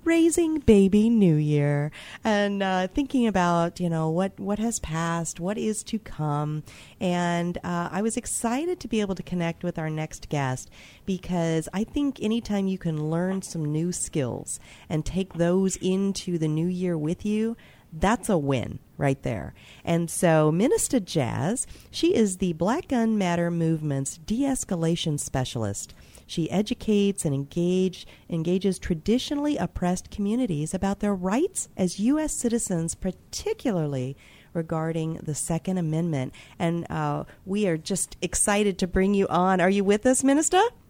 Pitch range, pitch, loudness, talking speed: 160-210 Hz, 180 Hz, -26 LUFS, 150 wpm